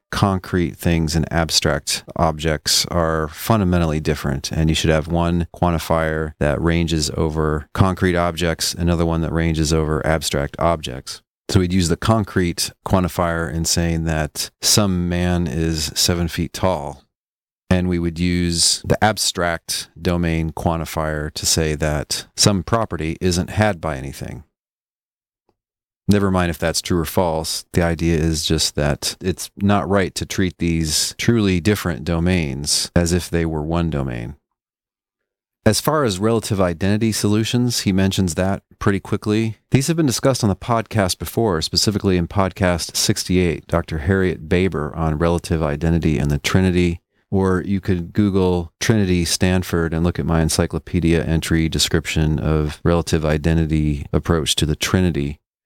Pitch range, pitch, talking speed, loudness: 80-95 Hz, 85 Hz, 150 wpm, -19 LUFS